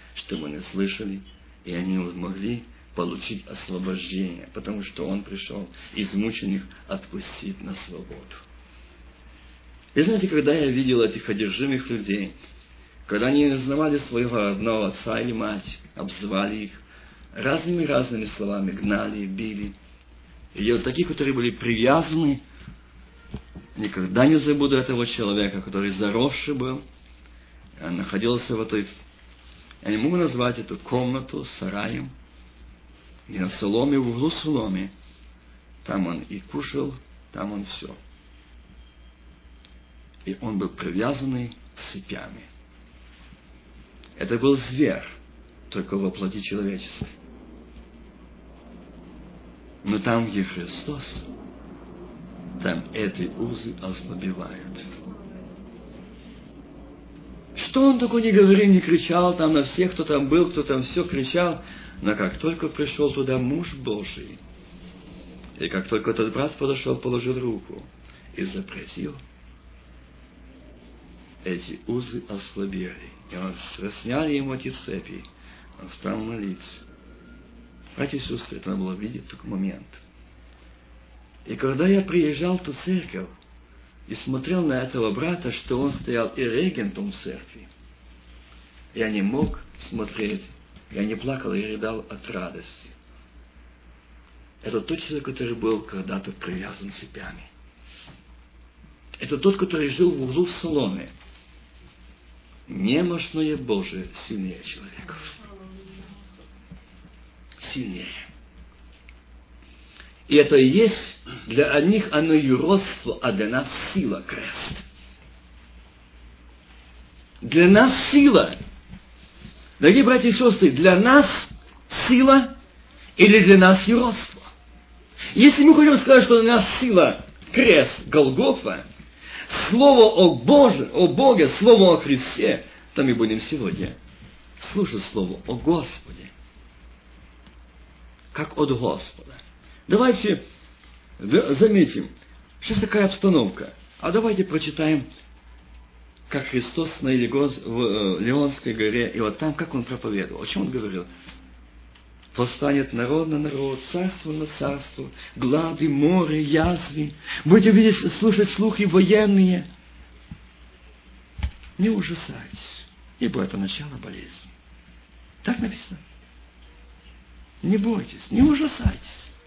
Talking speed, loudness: 110 wpm, -22 LUFS